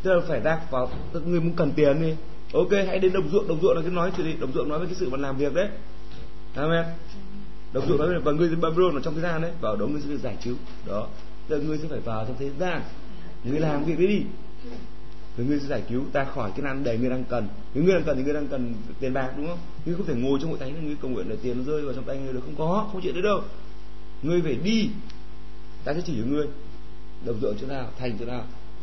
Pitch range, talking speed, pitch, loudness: 125-170 Hz, 280 wpm, 150 Hz, -27 LUFS